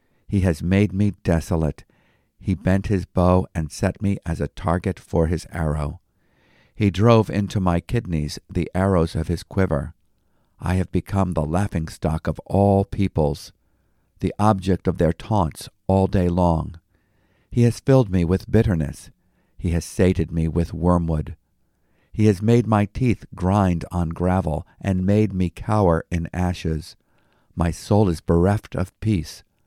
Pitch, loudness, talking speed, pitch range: 90 Hz, -22 LUFS, 155 wpm, 85-100 Hz